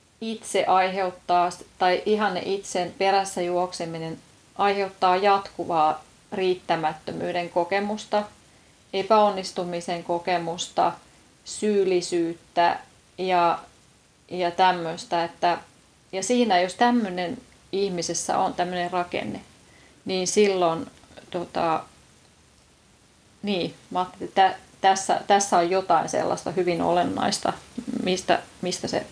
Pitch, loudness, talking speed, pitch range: 180 Hz, -24 LUFS, 90 wpm, 175-195 Hz